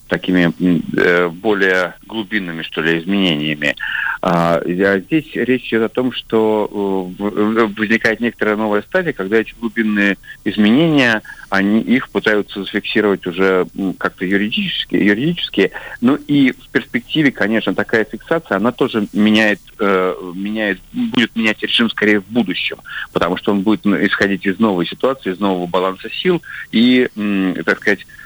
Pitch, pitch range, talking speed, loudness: 105 Hz, 95-115 Hz, 140 wpm, -16 LUFS